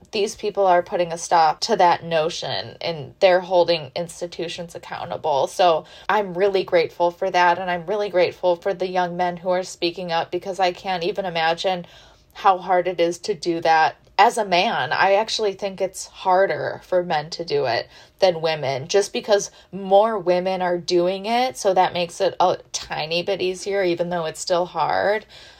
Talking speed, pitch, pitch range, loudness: 185 wpm, 180 Hz, 175-195 Hz, -21 LUFS